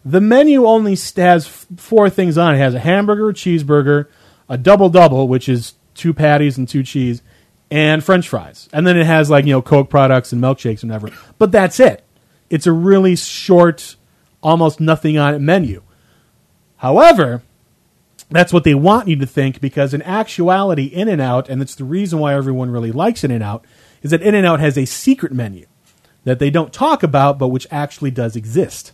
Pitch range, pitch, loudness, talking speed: 130-180 Hz, 150 Hz, -13 LUFS, 185 wpm